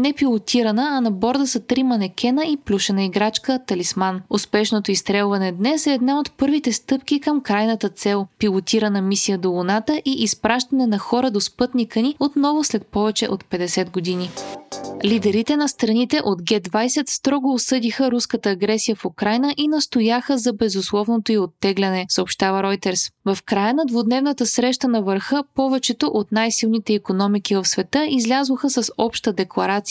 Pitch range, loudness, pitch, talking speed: 200-260 Hz, -19 LUFS, 225 Hz, 155 wpm